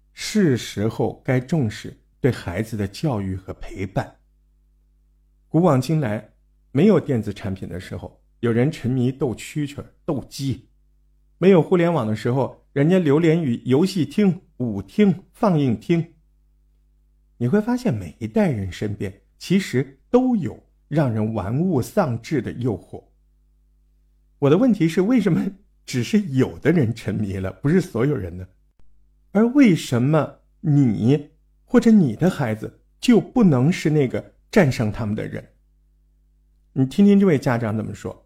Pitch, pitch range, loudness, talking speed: 120 Hz, 95-160 Hz, -21 LUFS, 215 characters per minute